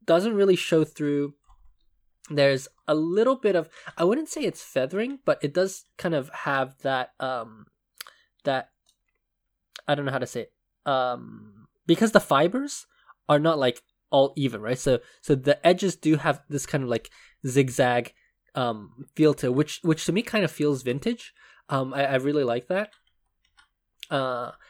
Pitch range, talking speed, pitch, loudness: 130-180 Hz, 170 wpm, 145 Hz, -25 LUFS